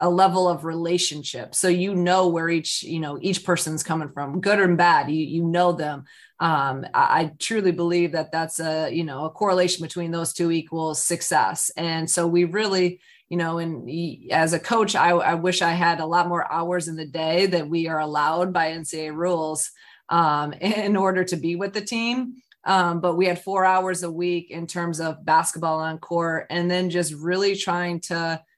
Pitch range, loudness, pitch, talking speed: 160-180 Hz, -23 LUFS, 170 Hz, 200 wpm